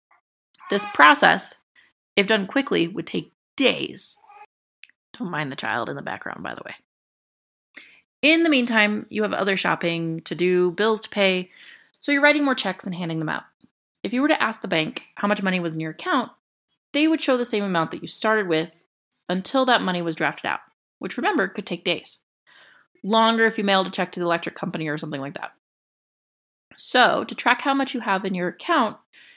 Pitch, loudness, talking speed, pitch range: 200 Hz, -22 LUFS, 200 wpm, 175-250 Hz